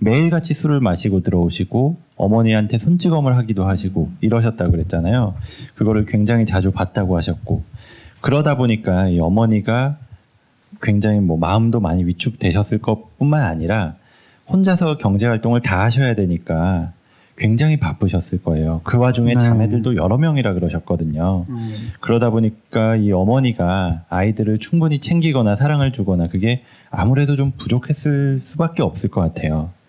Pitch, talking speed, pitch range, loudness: 110 Hz, 355 characters per minute, 95-125 Hz, -18 LUFS